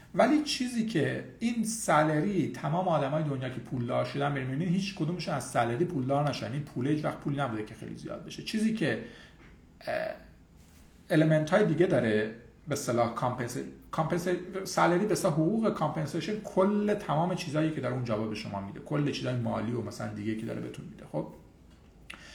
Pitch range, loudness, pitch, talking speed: 110-180 Hz, -30 LUFS, 145 Hz, 165 wpm